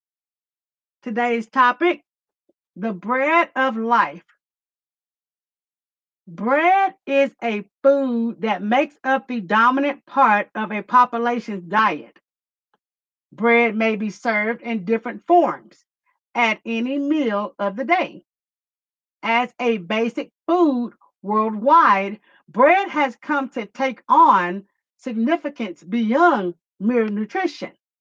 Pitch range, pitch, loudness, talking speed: 215-275 Hz, 235 Hz, -20 LUFS, 105 wpm